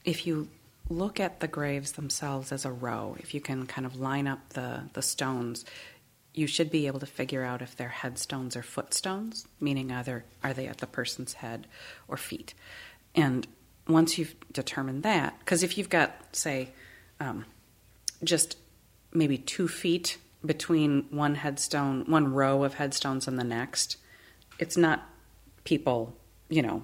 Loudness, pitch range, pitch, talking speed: -30 LUFS, 125-160 Hz, 140 Hz, 160 wpm